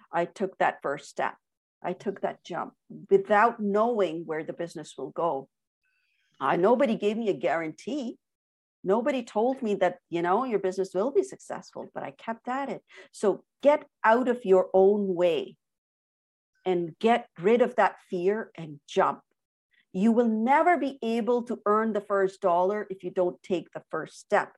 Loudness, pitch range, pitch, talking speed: -27 LUFS, 180-235 Hz, 200 Hz, 170 wpm